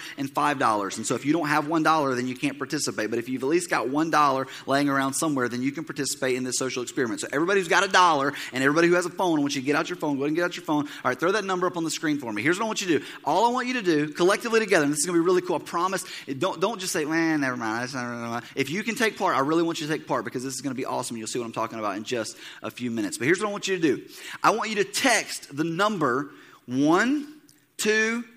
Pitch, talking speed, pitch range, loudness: 160 Hz, 330 wpm, 135-195 Hz, -25 LUFS